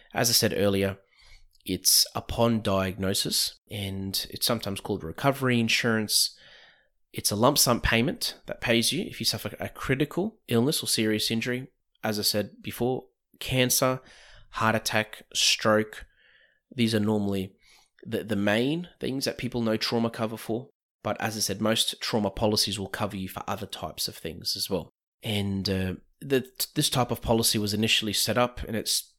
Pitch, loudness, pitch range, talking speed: 110 Hz, -26 LUFS, 100-120 Hz, 165 wpm